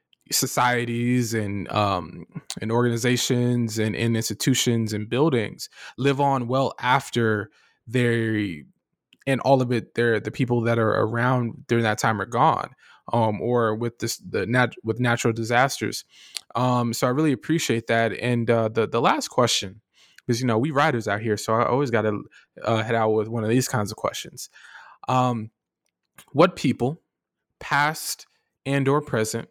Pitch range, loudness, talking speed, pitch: 110-125 Hz, -23 LUFS, 165 wpm, 120 Hz